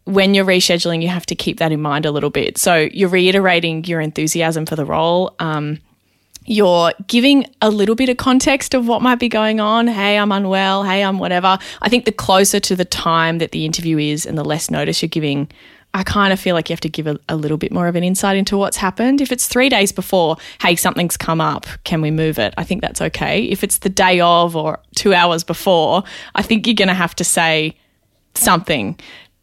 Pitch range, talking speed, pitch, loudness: 165-200 Hz, 230 wpm, 180 Hz, -15 LUFS